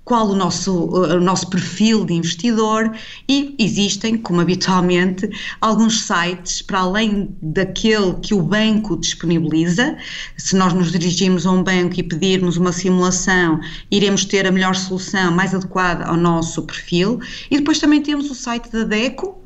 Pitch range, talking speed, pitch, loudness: 180-220 Hz, 155 wpm, 190 Hz, -17 LUFS